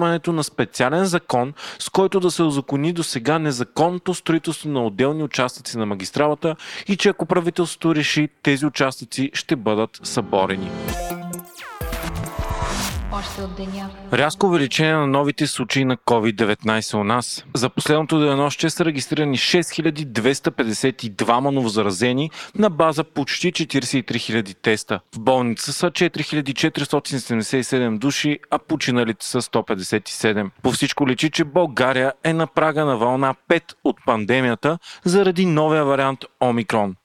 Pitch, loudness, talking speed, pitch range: 145 Hz, -20 LUFS, 125 wpm, 125-165 Hz